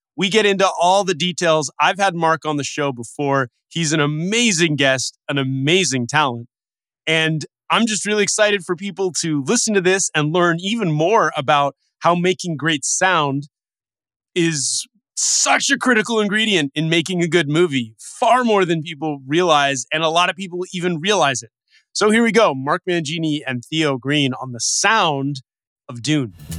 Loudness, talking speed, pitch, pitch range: -18 LUFS, 175 wpm, 165 Hz, 145-190 Hz